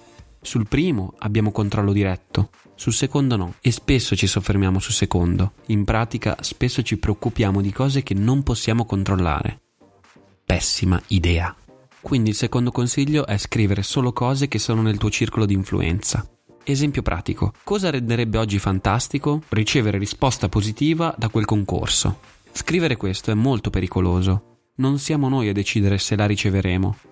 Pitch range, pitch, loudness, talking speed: 100-125 Hz, 110 Hz, -21 LUFS, 150 wpm